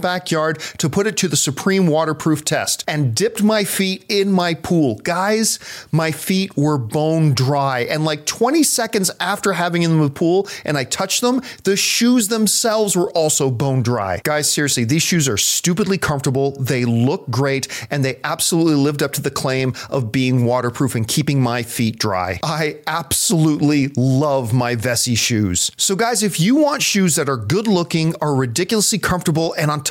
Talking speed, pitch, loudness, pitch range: 185 wpm, 155 Hz, -17 LUFS, 135-190 Hz